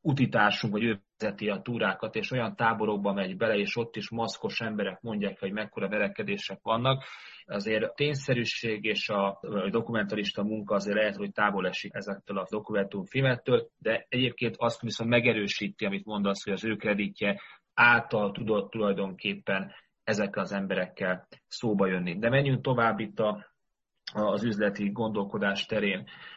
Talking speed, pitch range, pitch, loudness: 145 wpm, 100-115 Hz, 105 Hz, -29 LUFS